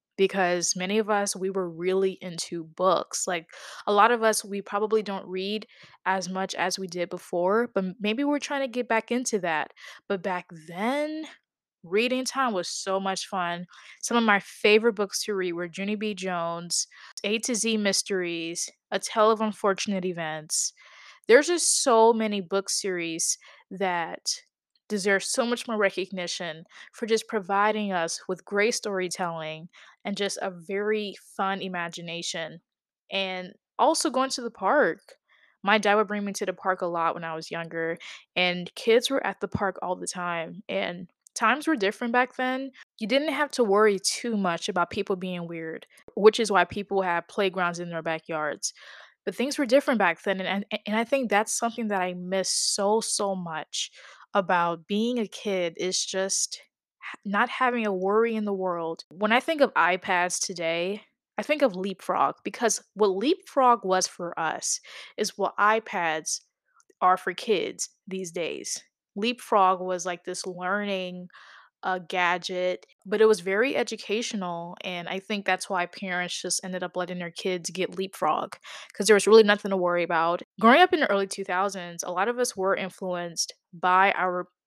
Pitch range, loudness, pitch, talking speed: 180-220 Hz, -26 LUFS, 195 Hz, 175 wpm